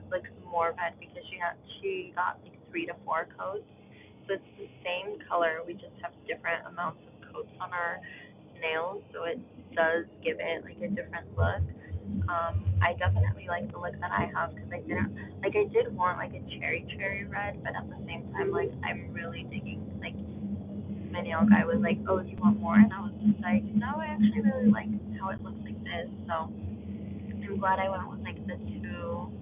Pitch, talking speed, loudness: 145 Hz, 210 wpm, -31 LUFS